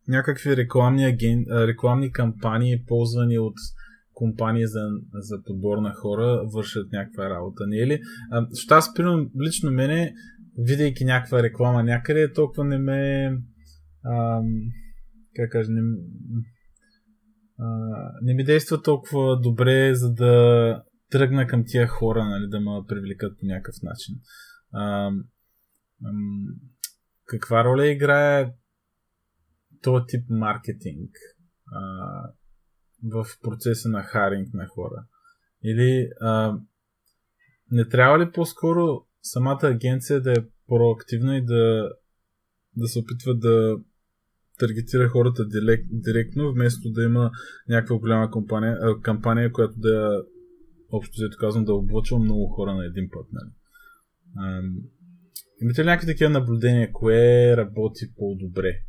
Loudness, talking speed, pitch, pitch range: -23 LUFS, 120 wpm, 115 Hz, 110-135 Hz